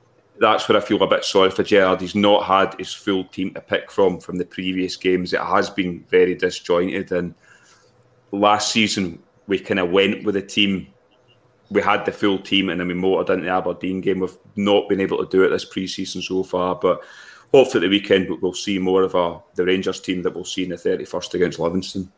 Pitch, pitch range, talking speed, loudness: 95 Hz, 90-100 Hz, 220 wpm, -20 LUFS